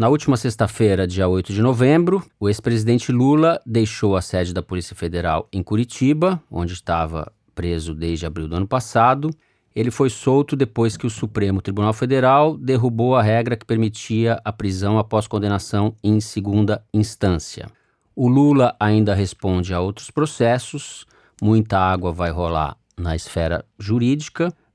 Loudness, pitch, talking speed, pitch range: -20 LUFS, 110 Hz, 150 wpm, 95-125 Hz